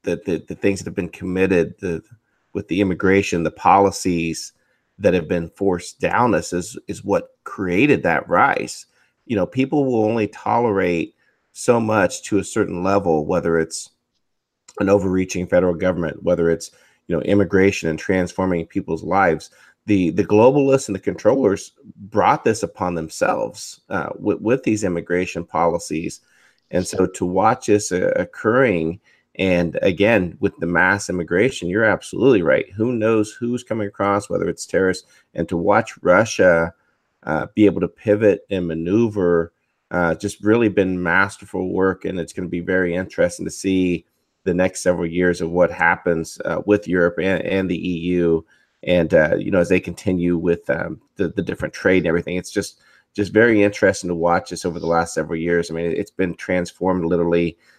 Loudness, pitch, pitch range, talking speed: -19 LUFS, 90 Hz, 85-100 Hz, 175 wpm